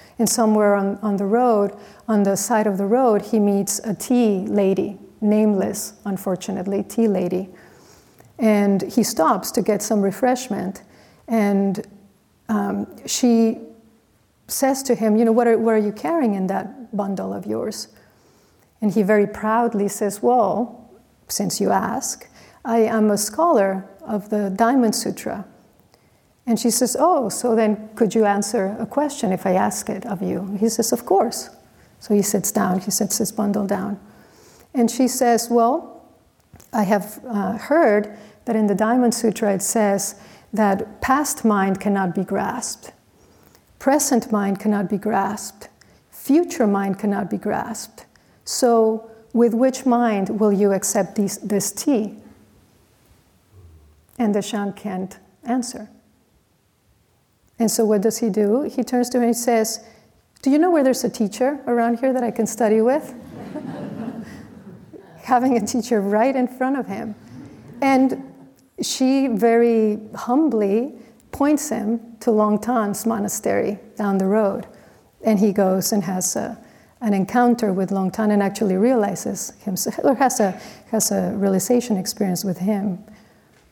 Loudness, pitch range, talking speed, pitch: -20 LUFS, 200-235 Hz, 150 wpm, 215 Hz